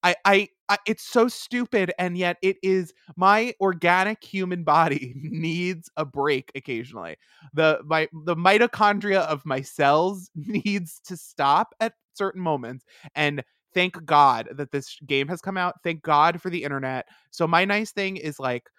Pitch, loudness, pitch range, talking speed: 175 Hz, -23 LUFS, 155-195 Hz, 165 wpm